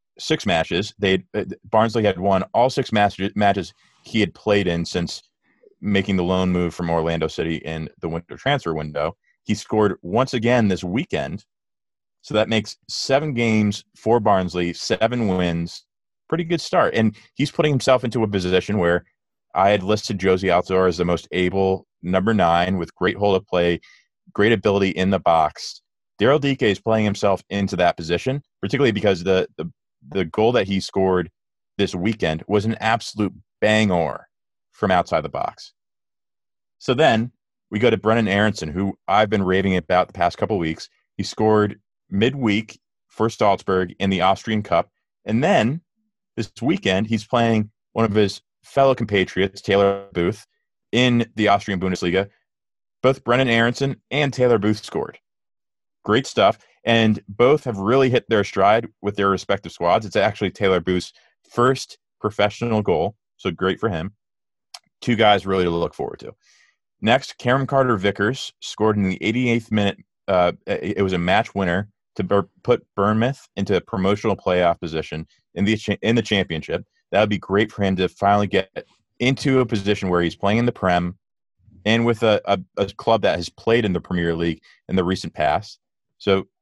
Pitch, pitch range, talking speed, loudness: 100 Hz, 95-110 Hz, 170 wpm, -21 LUFS